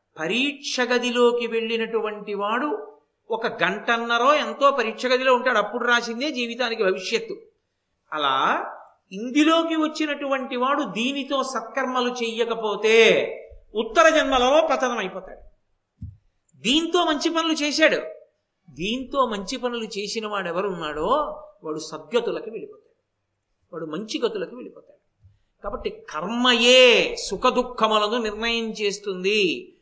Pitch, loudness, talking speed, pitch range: 250 Hz, -22 LUFS, 95 wpm, 215-300 Hz